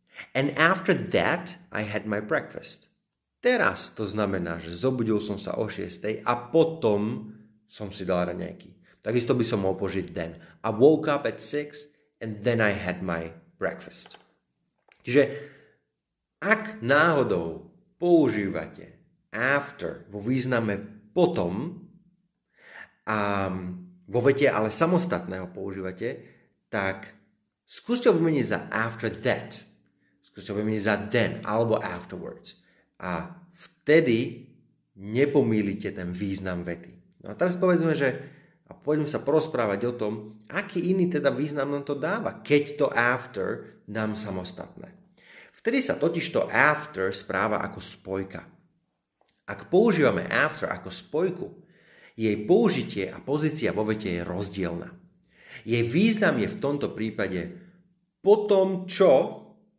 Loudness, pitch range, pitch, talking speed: -26 LUFS, 100-160 Hz, 120 Hz, 125 wpm